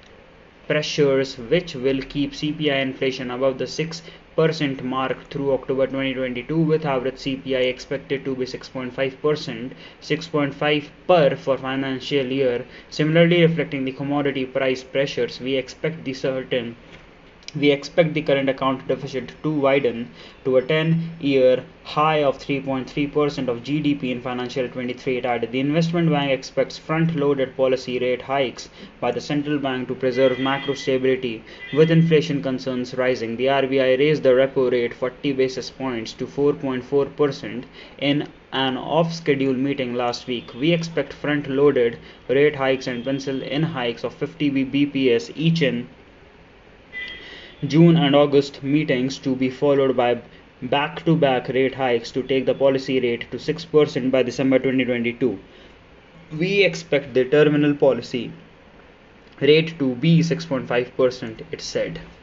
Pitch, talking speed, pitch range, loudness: 135 Hz, 150 wpm, 130-145 Hz, -21 LUFS